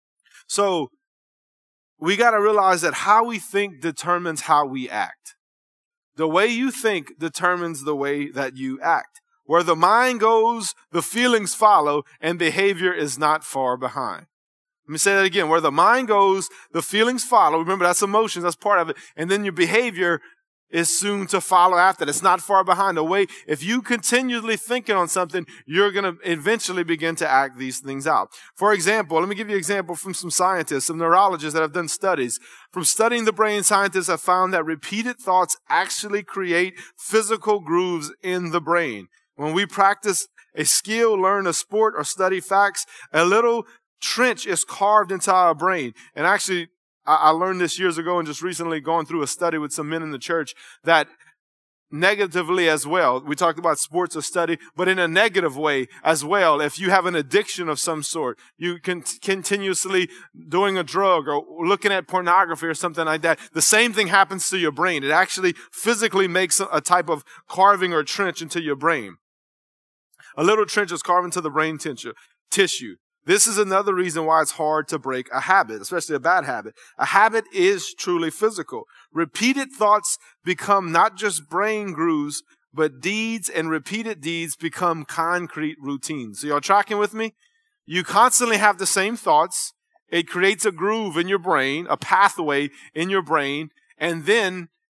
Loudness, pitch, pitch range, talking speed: -21 LUFS, 180 Hz, 160-205 Hz, 180 wpm